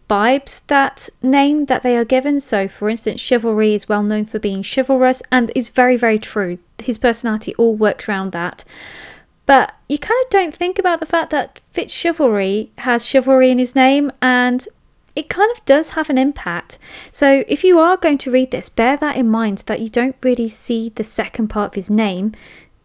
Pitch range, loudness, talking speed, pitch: 220-275 Hz, -16 LUFS, 200 wpm, 250 Hz